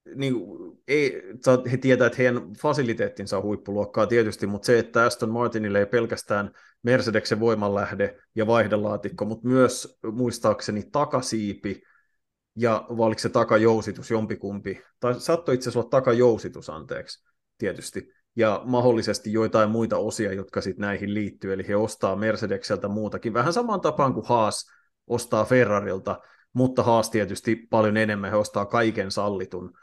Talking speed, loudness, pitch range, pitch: 135 wpm, -24 LUFS, 105-120 Hz, 110 Hz